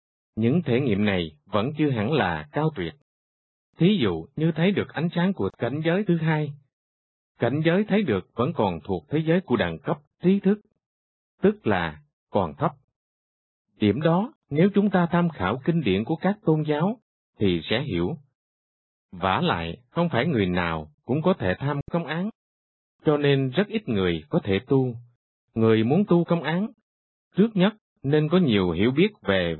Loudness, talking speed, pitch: -24 LUFS, 180 wpm, 145 Hz